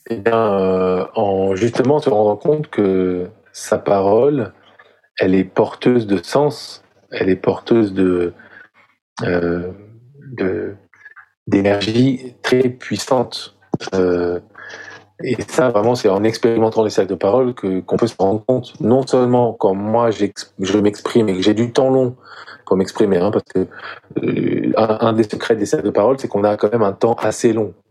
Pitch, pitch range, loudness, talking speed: 110 Hz, 95-120 Hz, -17 LUFS, 165 wpm